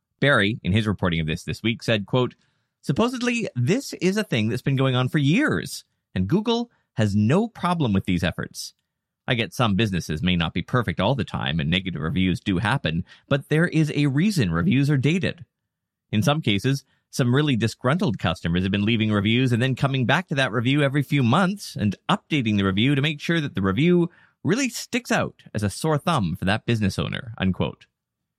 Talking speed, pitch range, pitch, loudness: 205 wpm, 105-160 Hz, 130 Hz, -23 LUFS